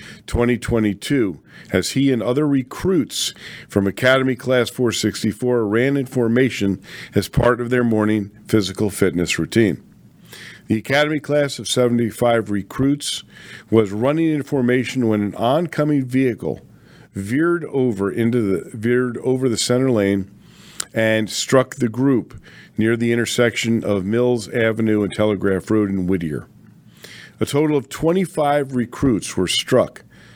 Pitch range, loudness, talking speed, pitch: 105-130 Hz, -19 LUFS, 130 wpm, 120 Hz